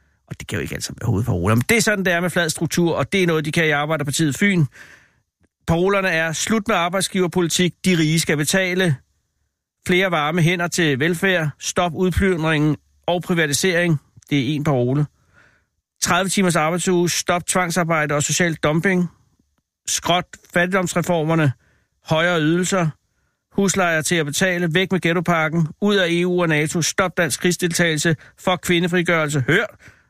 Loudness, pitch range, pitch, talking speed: -19 LUFS, 155-180 Hz, 170 Hz, 150 wpm